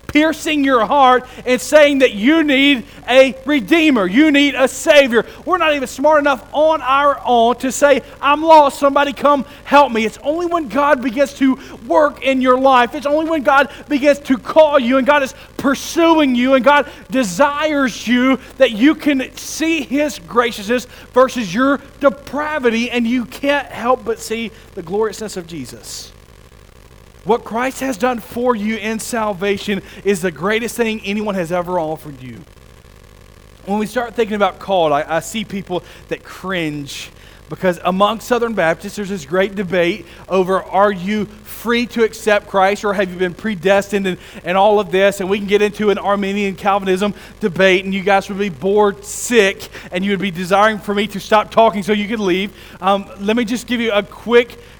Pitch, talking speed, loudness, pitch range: 225 Hz, 185 wpm, -15 LUFS, 195-275 Hz